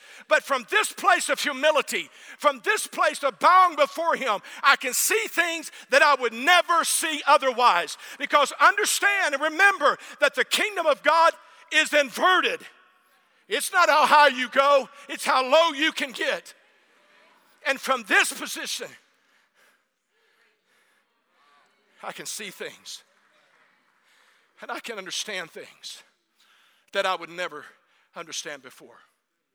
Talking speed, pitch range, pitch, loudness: 130 wpm, 275-340 Hz, 300 Hz, -22 LUFS